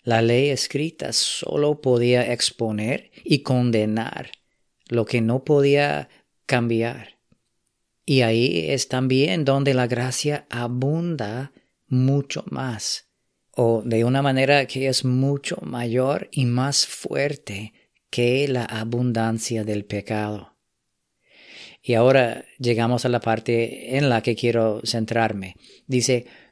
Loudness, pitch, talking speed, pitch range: -22 LUFS, 125 Hz, 115 wpm, 115-135 Hz